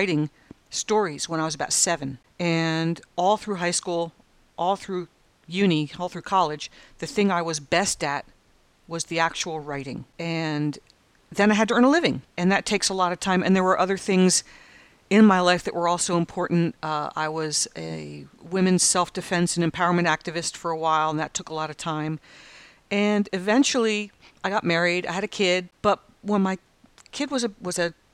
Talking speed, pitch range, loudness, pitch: 195 wpm, 160-195 Hz, -24 LUFS, 175 Hz